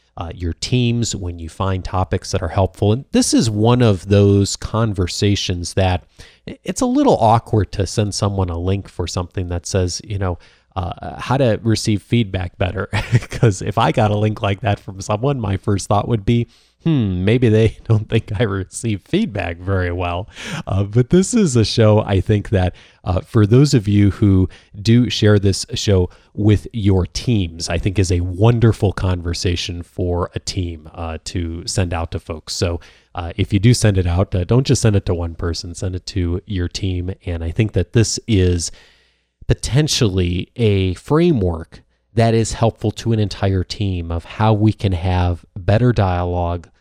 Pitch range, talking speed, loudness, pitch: 90-110 Hz, 185 wpm, -18 LUFS, 100 Hz